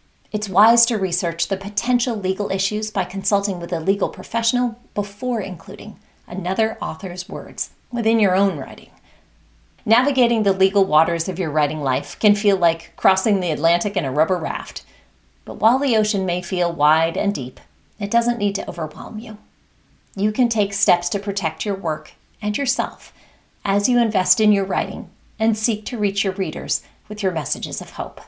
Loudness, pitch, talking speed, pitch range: -20 LUFS, 200 Hz, 175 wpm, 180-220 Hz